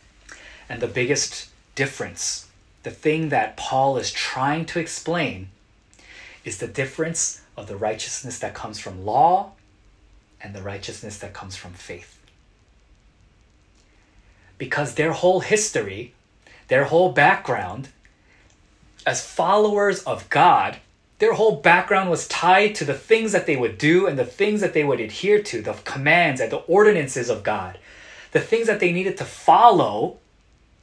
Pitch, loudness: 145 Hz, -20 LUFS